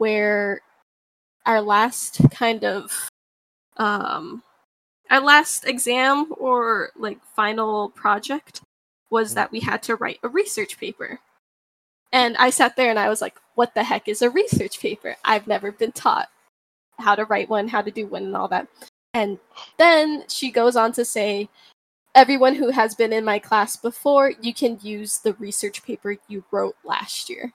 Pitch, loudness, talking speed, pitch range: 230 Hz, -20 LUFS, 170 wpm, 210-260 Hz